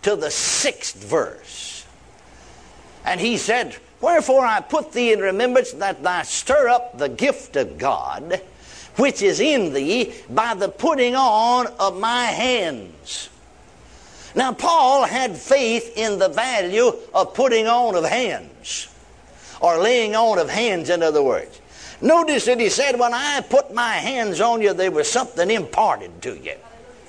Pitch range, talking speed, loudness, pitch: 220-315 Hz, 155 wpm, -19 LUFS, 245 Hz